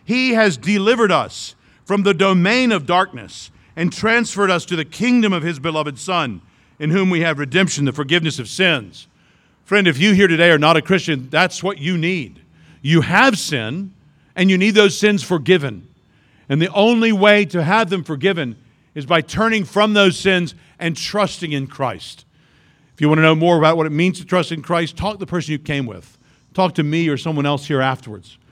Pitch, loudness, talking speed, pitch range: 170 Hz, -16 LUFS, 205 wpm, 145-195 Hz